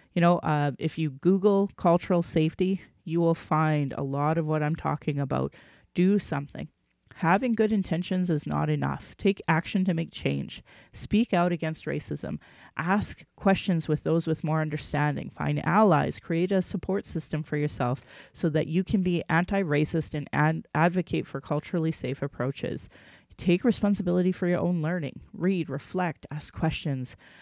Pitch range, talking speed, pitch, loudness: 150-180 Hz, 160 wpm, 165 Hz, -27 LUFS